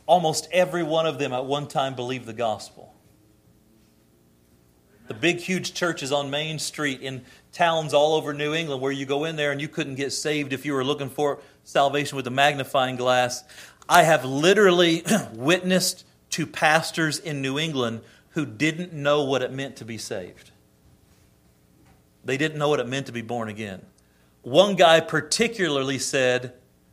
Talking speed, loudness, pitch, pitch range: 170 wpm, -23 LUFS, 145 Hz, 125-160 Hz